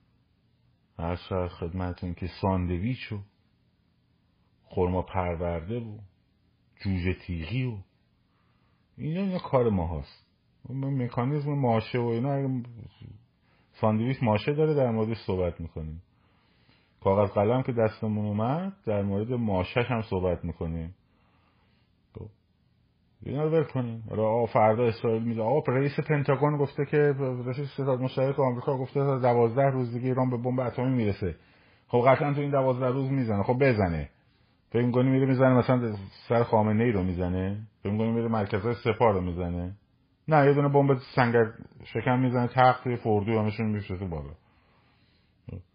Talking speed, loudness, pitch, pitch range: 130 wpm, -27 LUFS, 115 Hz, 95-130 Hz